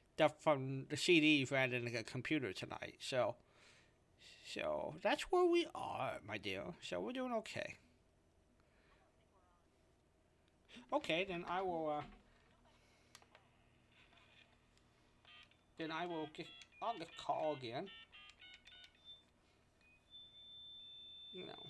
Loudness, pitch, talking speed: -40 LUFS, 125 Hz, 95 wpm